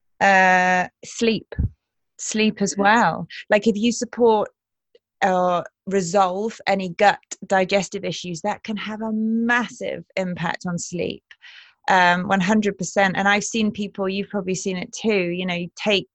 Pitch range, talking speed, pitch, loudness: 185-215 Hz, 145 wpm, 200 Hz, -21 LUFS